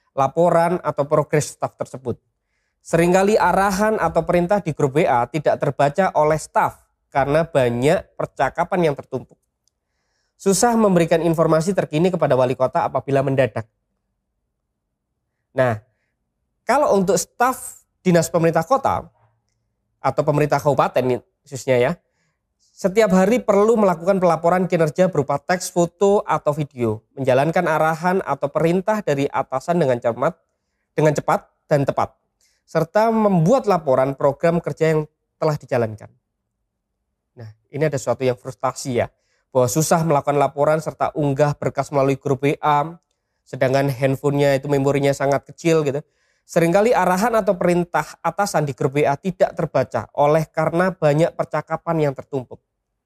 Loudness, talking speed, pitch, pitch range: -19 LUFS, 130 wpm, 150 Hz, 135-170 Hz